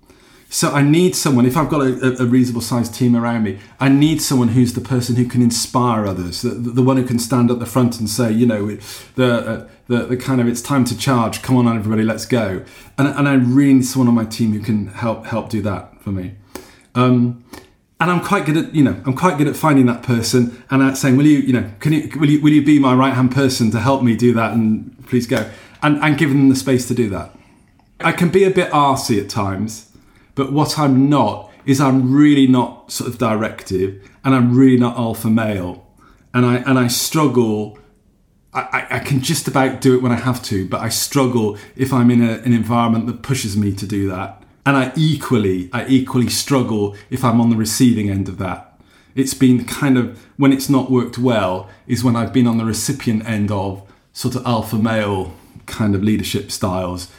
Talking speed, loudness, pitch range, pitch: 225 wpm, -16 LUFS, 110-135 Hz, 120 Hz